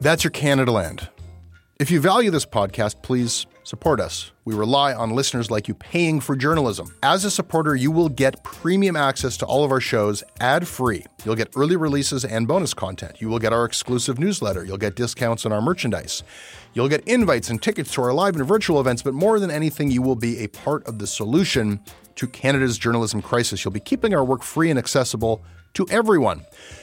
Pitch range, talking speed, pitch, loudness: 105-150 Hz, 205 wpm, 125 Hz, -21 LUFS